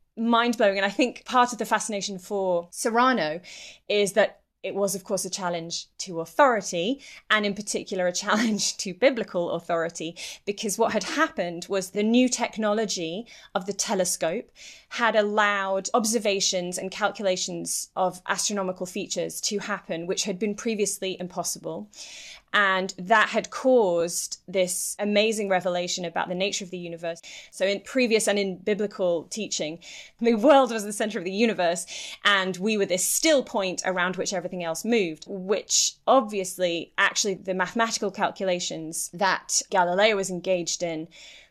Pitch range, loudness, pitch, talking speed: 180-220 Hz, -25 LUFS, 195 Hz, 150 wpm